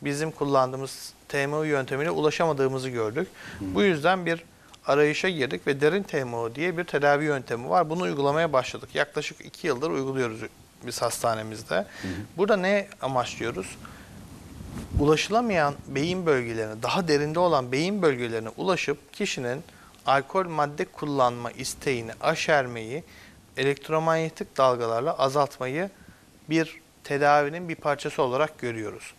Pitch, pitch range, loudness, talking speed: 145 Hz, 125-160 Hz, -26 LUFS, 115 wpm